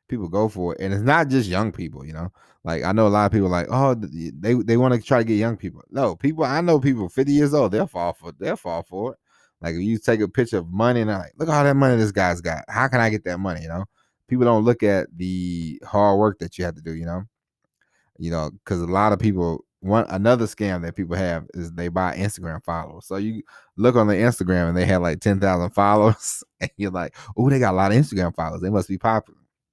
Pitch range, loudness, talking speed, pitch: 90-115 Hz, -21 LUFS, 270 wpm, 100 Hz